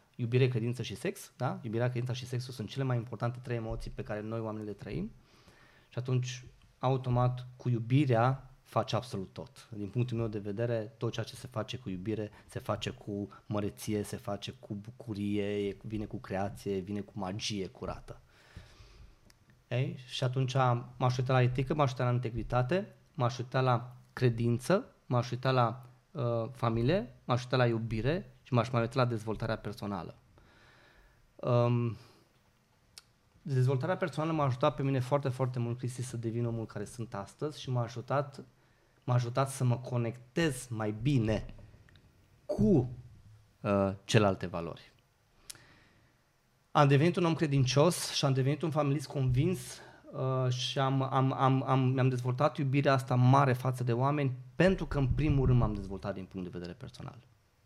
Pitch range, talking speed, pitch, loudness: 110-130 Hz, 160 wpm, 120 Hz, -32 LUFS